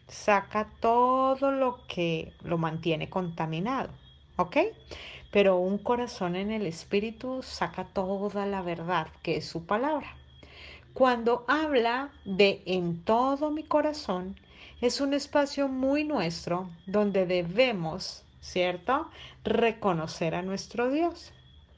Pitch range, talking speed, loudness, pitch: 175-255 Hz, 115 wpm, -29 LUFS, 200 Hz